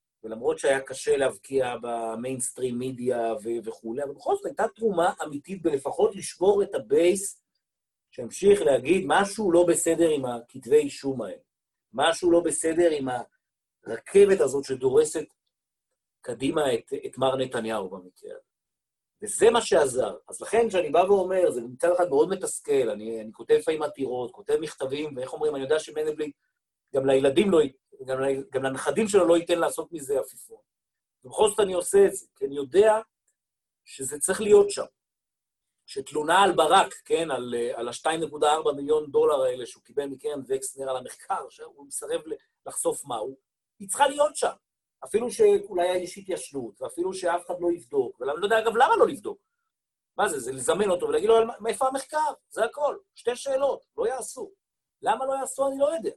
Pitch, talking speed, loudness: 210 Hz, 160 wpm, -25 LUFS